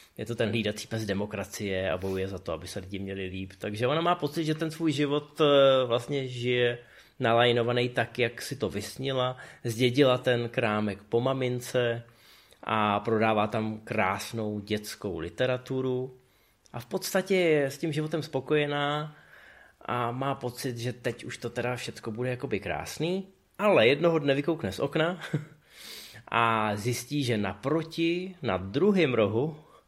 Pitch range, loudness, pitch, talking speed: 110-145 Hz, -28 LUFS, 125 Hz, 150 wpm